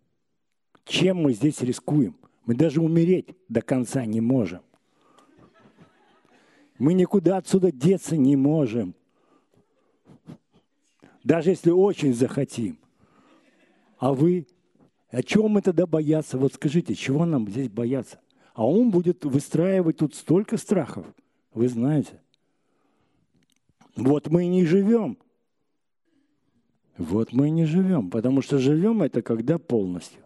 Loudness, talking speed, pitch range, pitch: -23 LUFS, 115 wpm, 130-180 Hz, 150 Hz